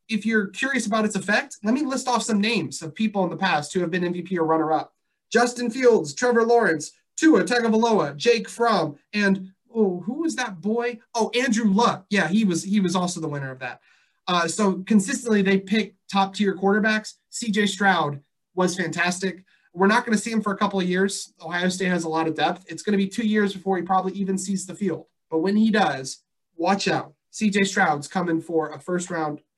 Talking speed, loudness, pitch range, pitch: 210 wpm, -23 LUFS, 175-220 Hz, 195 Hz